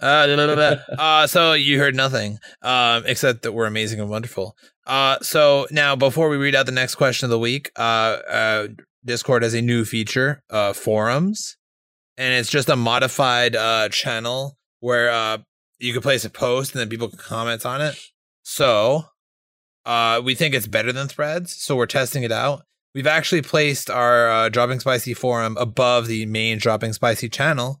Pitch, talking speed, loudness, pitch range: 125 Hz, 190 wpm, -19 LUFS, 115-140 Hz